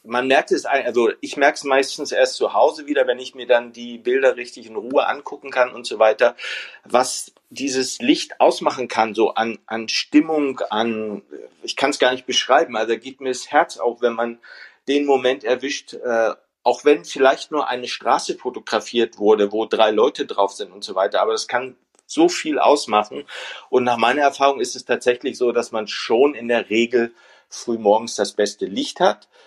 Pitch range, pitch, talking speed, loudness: 115-155 Hz, 130 Hz, 200 wpm, -20 LUFS